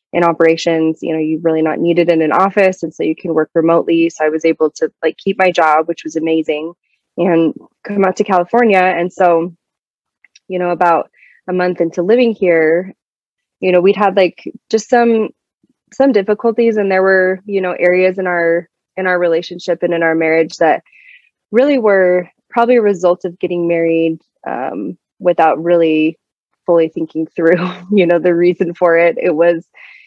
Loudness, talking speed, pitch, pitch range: -14 LUFS, 180 wpm, 175 Hz, 165-190 Hz